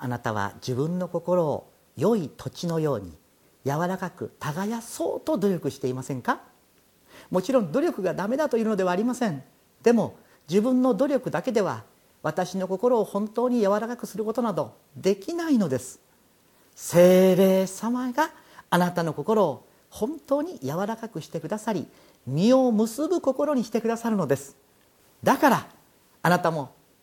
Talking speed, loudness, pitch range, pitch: 310 characters per minute, -25 LUFS, 155-235 Hz, 190 Hz